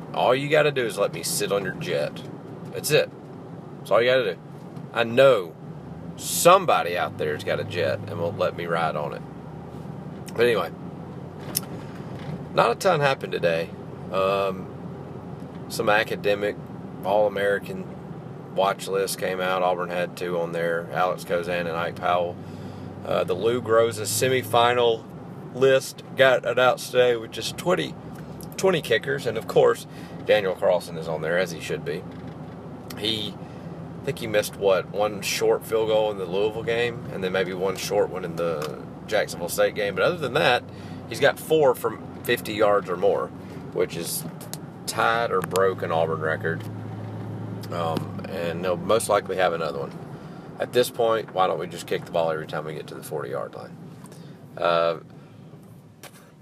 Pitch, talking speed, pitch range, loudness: 115 Hz, 170 wpm, 95-150 Hz, -24 LUFS